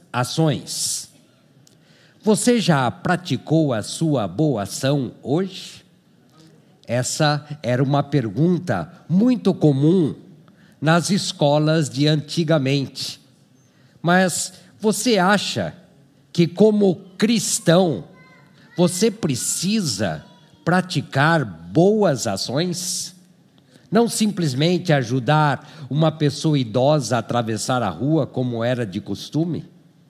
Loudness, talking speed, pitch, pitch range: -20 LUFS, 90 wpm, 155 Hz, 140-180 Hz